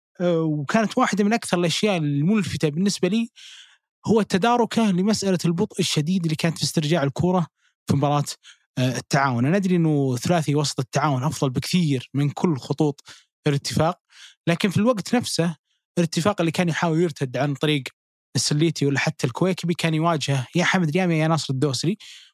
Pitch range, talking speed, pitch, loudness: 145-185 Hz, 150 wpm, 165 Hz, -22 LUFS